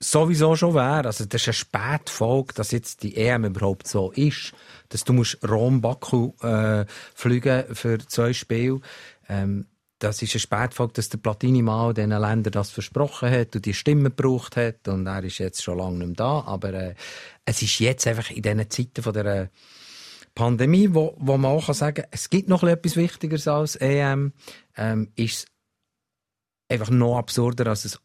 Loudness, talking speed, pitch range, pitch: -23 LUFS, 180 wpm, 105-135 Hz, 115 Hz